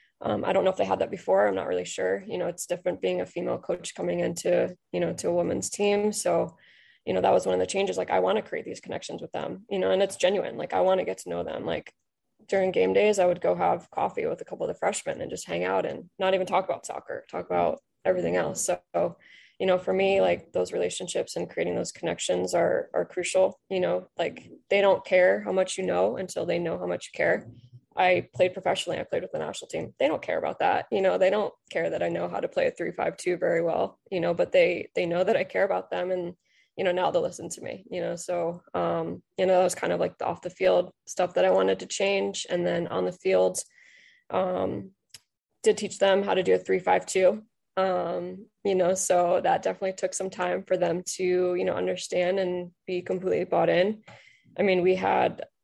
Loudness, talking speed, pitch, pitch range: -27 LUFS, 245 wpm, 185 Hz, 175-195 Hz